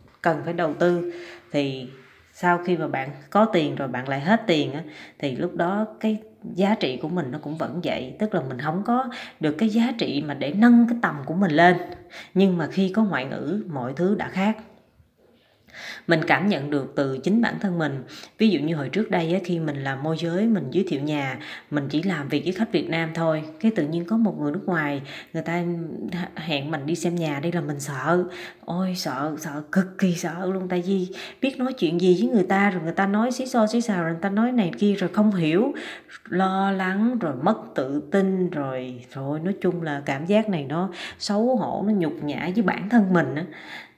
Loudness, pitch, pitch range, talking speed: -24 LUFS, 175 Hz, 155-205 Hz, 230 wpm